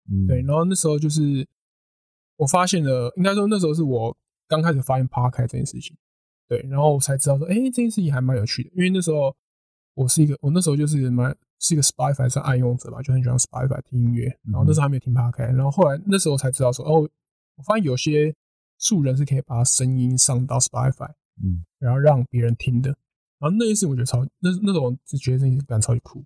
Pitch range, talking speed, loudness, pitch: 125-155 Hz, 410 characters per minute, -21 LUFS, 135 Hz